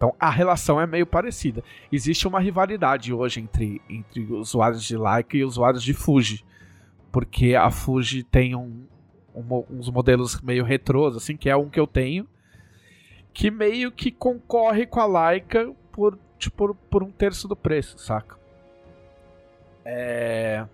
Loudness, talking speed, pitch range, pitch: -23 LUFS, 150 wpm, 115-175 Hz, 130 Hz